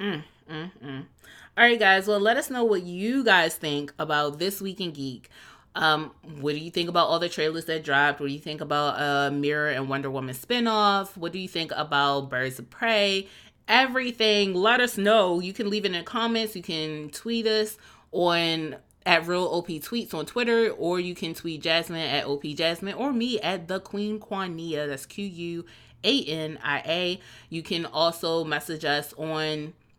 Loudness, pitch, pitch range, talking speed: -25 LUFS, 170 Hz, 150-200 Hz, 200 wpm